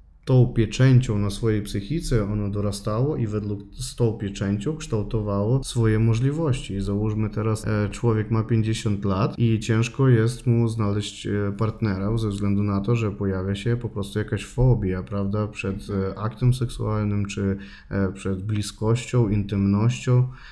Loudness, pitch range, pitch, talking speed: -24 LUFS, 100-120 Hz, 110 Hz, 130 wpm